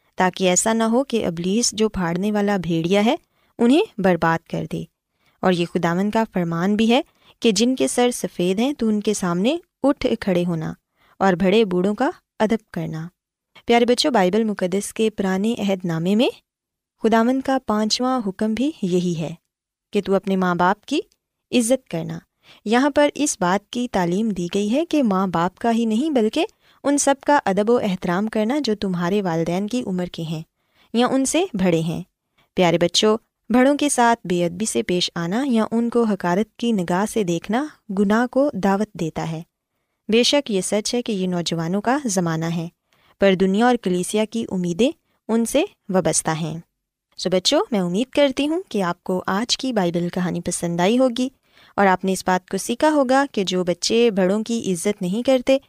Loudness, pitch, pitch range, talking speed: -20 LUFS, 205 Hz, 180-245 Hz, 190 wpm